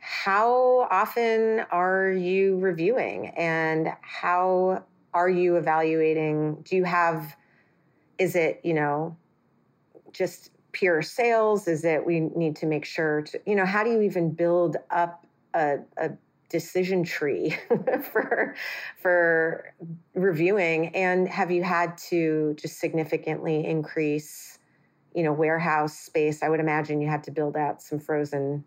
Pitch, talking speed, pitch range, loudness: 170 Hz, 135 wpm, 155-185 Hz, -25 LUFS